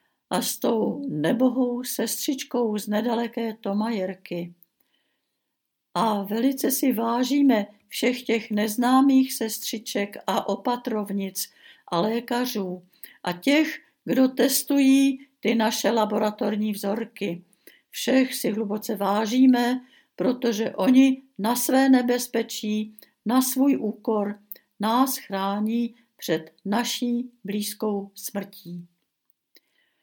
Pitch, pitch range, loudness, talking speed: 230 Hz, 205-255 Hz, -24 LUFS, 90 wpm